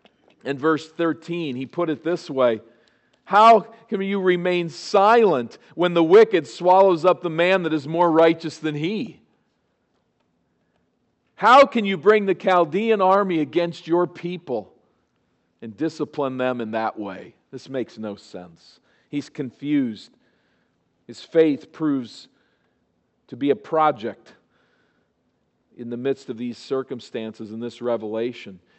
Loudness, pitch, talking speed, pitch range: -21 LUFS, 155 Hz, 135 wpm, 125-180 Hz